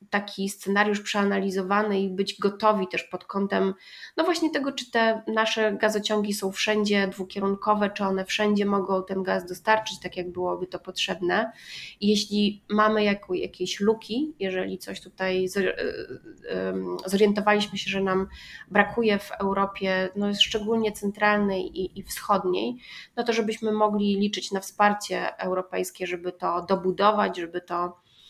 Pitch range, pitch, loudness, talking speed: 185-210 Hz, 200 Hz, -26 LUFS, 140 wpm